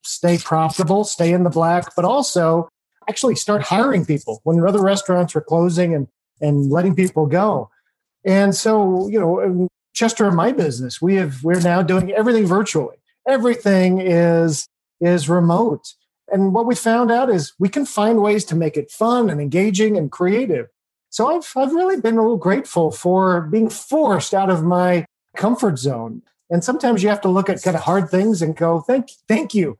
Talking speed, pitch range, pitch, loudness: 185 wpm, 170-220 Hz, 185 Hz, -18 LUFS